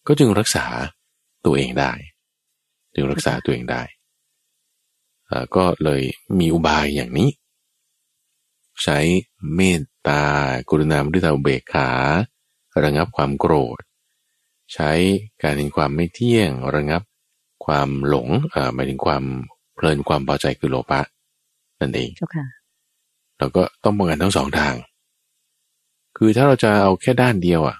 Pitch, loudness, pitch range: 75 Hz, -19 LUFS, 70-95 Hz